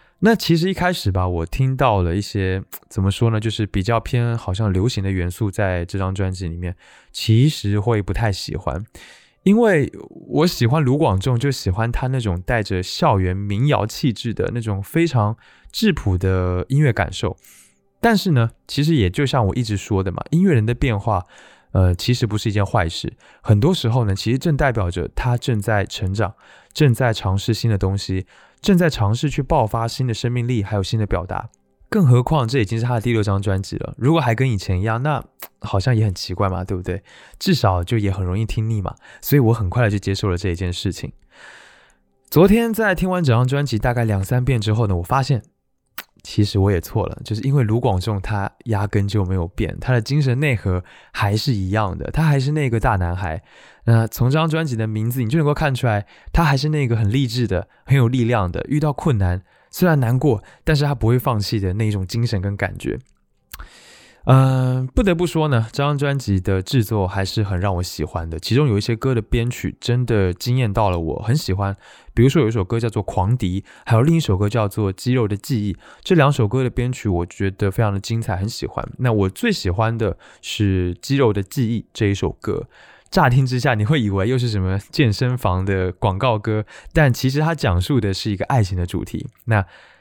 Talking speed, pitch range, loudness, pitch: 300 characters per minute, 95-130 Hz, -20 LUFS, 110 Hz